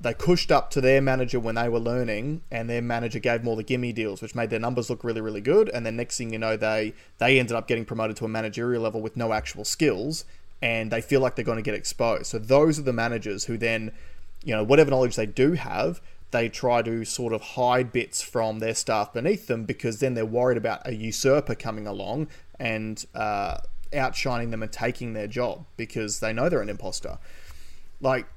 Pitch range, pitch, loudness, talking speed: 110-125 Hz, 115 Hz, -26 LUFS, 225 wpm